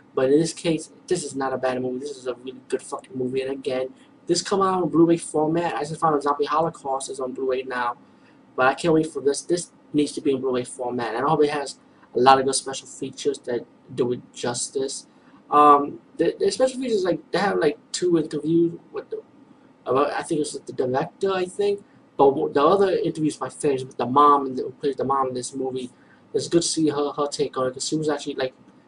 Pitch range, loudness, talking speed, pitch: 130-170 Hz, -23 LUFS, 245 wpm, 145 Hz